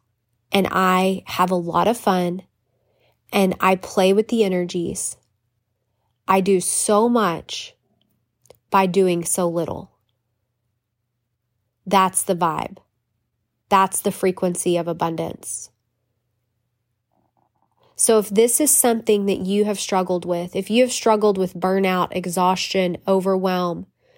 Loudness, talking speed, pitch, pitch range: -20 LUFS, 115 wpm, 180 Hz, 120-195 Hz